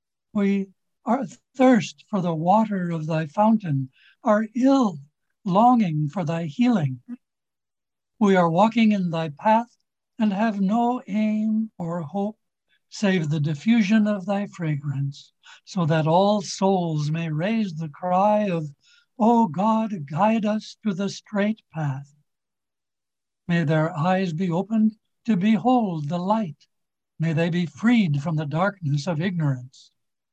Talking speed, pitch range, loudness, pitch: 135 wpm, 160-215 Hz, -23 LUFS, 195 Hz